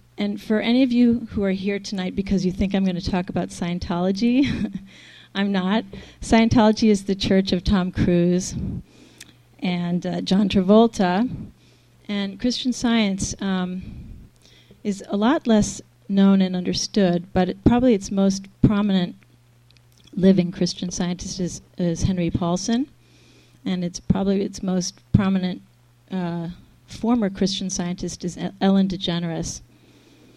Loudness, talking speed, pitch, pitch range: -22 LUFS, 135 wpm, 195 Hz, 180-205 Hz